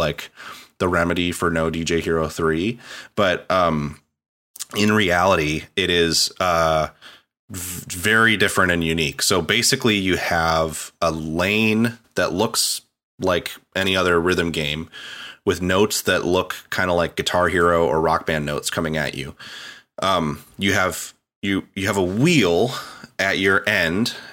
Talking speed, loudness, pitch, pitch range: 150 wpm, -20 LUFS, 85 Hz, 80-95 Hz